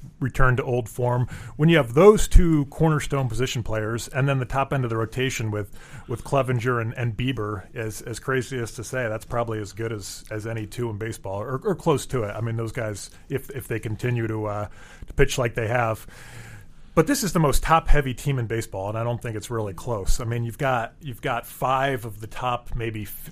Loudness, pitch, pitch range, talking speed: -25 LUFS, 120 Hz, 110-135 Hz, 235 wpm